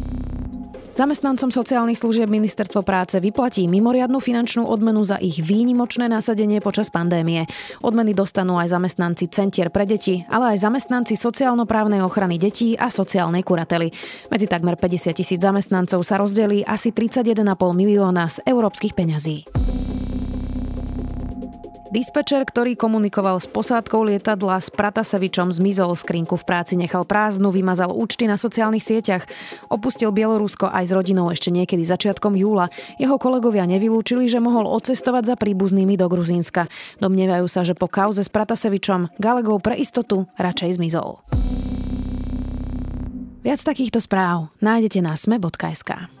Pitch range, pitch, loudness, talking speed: 180-225 Hz, 195 Hz, -20 LUFS, 130 wpm